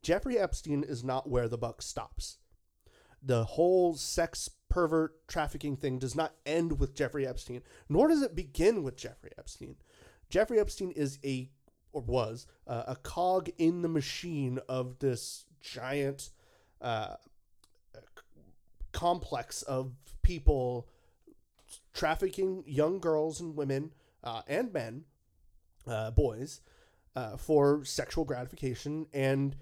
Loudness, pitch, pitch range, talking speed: -33 LUFS, 140 Hz, 130-160 Hz, 125 wpm